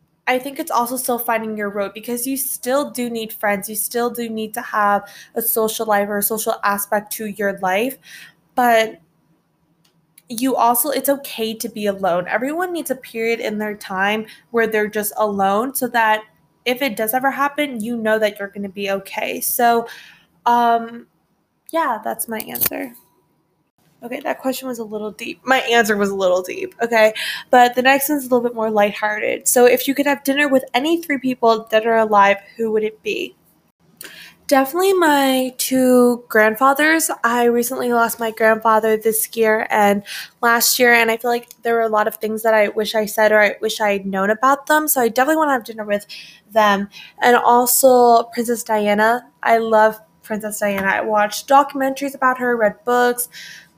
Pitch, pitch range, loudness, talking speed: 230 Hz, 215-255 Hz, -17 LUFS, 190 wpm